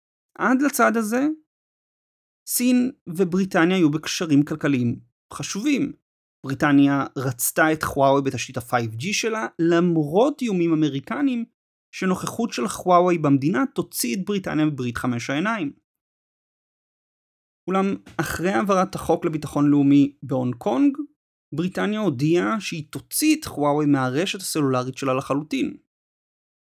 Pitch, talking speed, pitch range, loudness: 170 Hz, 105 wpm, 140-215 Hz, -22 LUFS